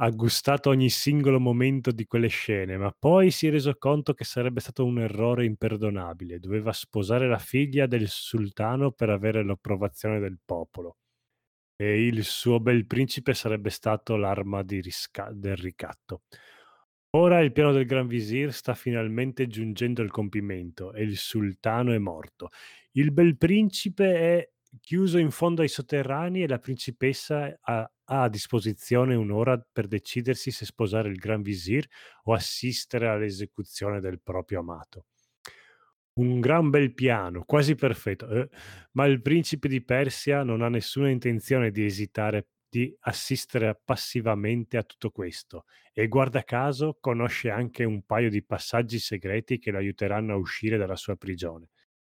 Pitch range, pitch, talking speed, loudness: 105-135 Hz, 115 Hz, 150 wpm, -26 LUFS